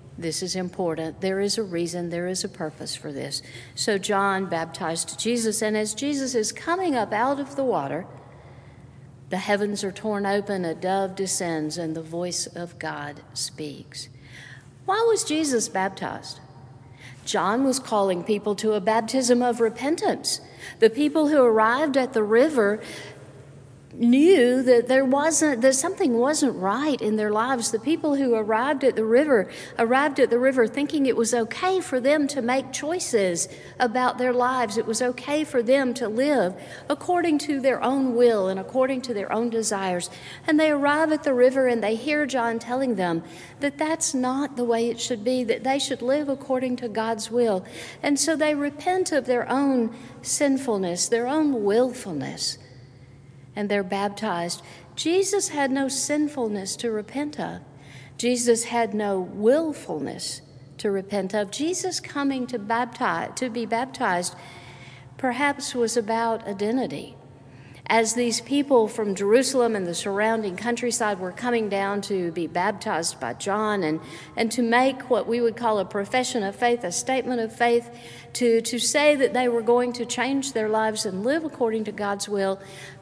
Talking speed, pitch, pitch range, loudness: 165 wpm, 230 Hz, 190-260 Hz, -24 LUFS